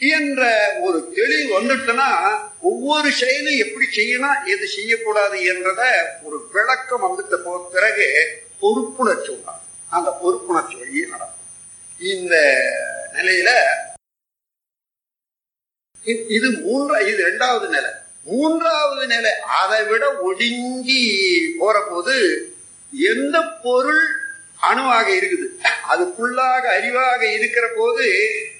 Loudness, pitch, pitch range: -17 LUFS, 295 Hz, 240-380 Hz